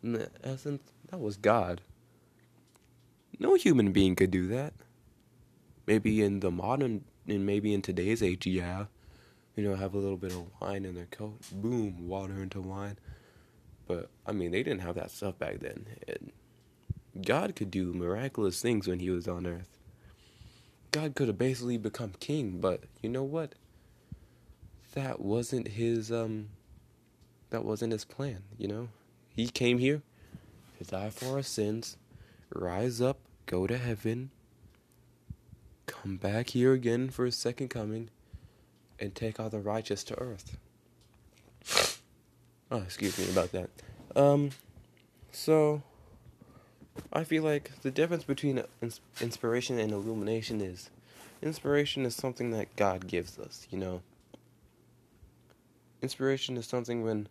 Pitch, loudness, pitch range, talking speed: 110 Hz, -33 LUFS, 100-125 Hz, 140 wpm